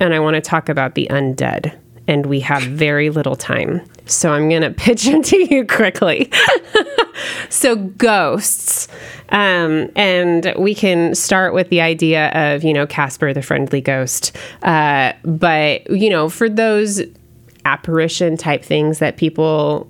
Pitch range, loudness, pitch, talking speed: 145-190 Hz, -15 LUFS, 160 Hz, 150 wpm